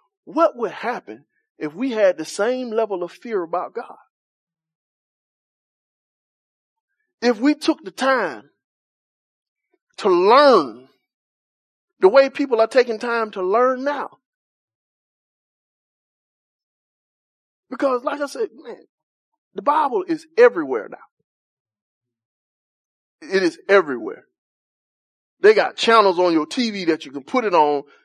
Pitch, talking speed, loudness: 250 Hz, 115 wpm, -19 LUFS